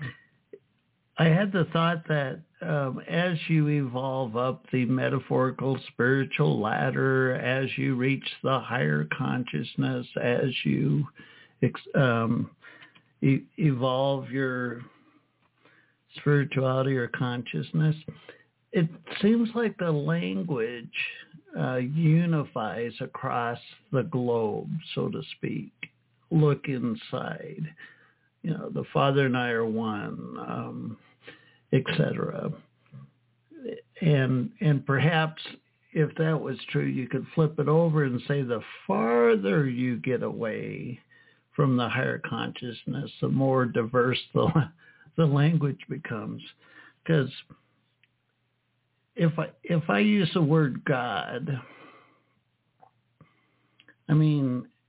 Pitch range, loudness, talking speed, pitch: 125-160 Hz, -27 LUFS, 105 wpm, 135 Hz